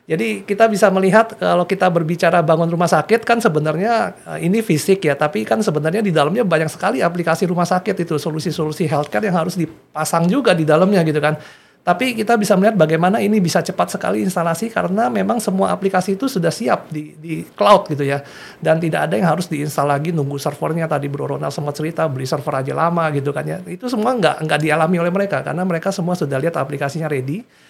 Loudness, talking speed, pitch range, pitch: -17 LUFS, 200 wpm, 155-195 Hz, 170 Hz